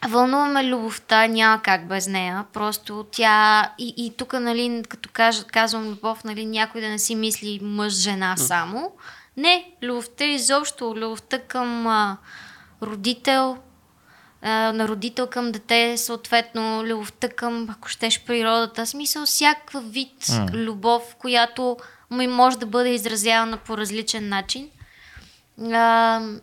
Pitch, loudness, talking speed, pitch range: 230 Hz, -21 LUFS, 125 wpm, 220-245 Hz